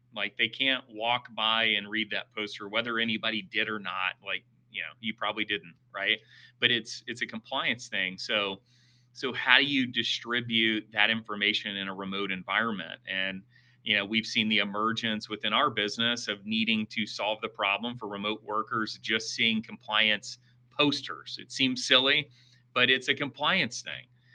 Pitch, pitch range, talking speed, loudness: 115 Hz, 105-125 Hz, 175 wpm, -28 LUFS